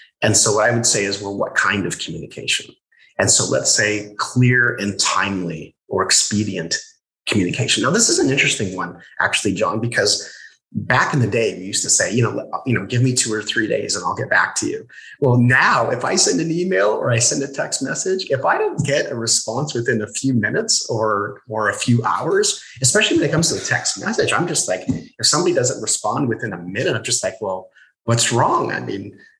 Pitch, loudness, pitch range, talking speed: 115 Hz, -18 LUFS, 105-135 Hz, 220 wpm